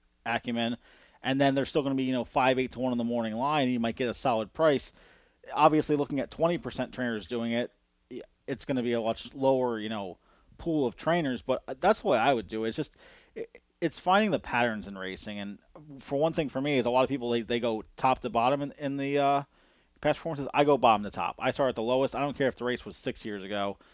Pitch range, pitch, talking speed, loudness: 115-140 Hz, 125 Hz, 255 wpm, -29 LUFS